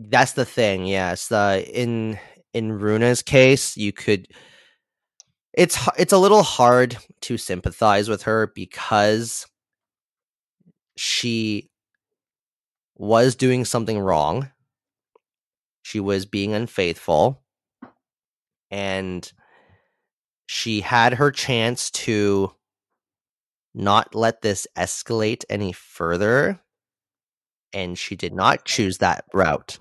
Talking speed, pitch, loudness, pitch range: 100 wpm, 110 Hz, -20 LUFS, 100-120 Hz